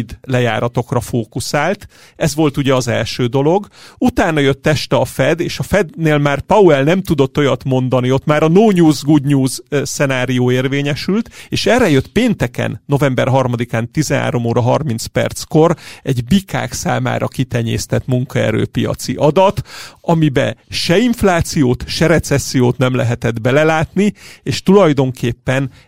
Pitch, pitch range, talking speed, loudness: 135 Hz, 125-155 Hz, 130 wpm, -15 LUFS